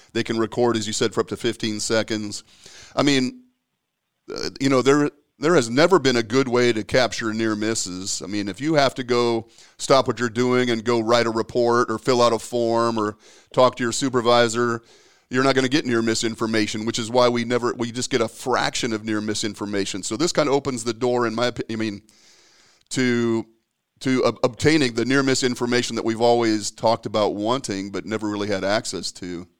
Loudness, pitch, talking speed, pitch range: -21 LUFS, 115 Hz, 210 wpm, 110-125 Hz